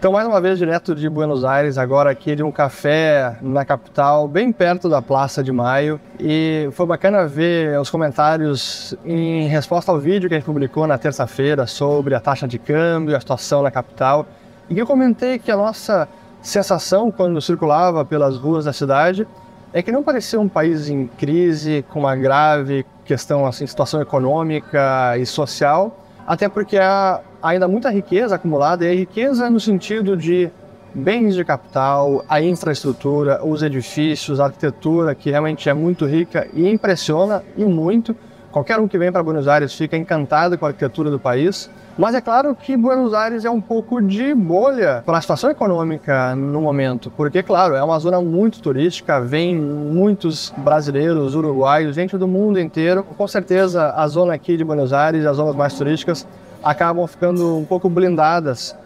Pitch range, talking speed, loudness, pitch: 145-190 Hz, 175 wpm, -17 LUFS, 160 Hz